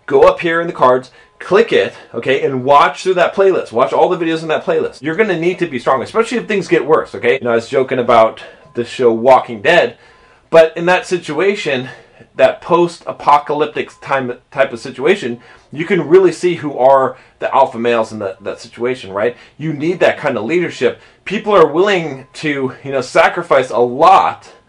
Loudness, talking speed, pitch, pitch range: -14 LUFS, 200 wpm, 150 Hz, 125-180 Hz